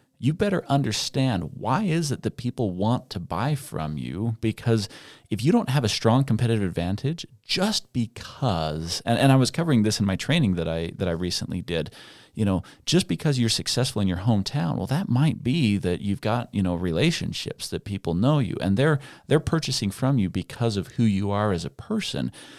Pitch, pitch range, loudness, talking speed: 115 Hz, 95-135 Hz, -25 LUFS, 200 wpm